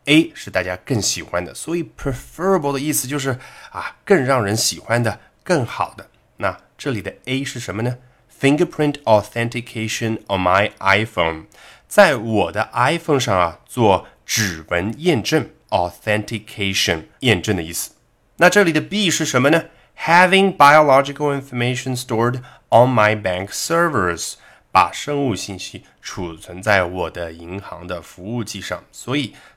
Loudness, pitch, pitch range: -18 LUFS, 120 Hz, 100-145 Hz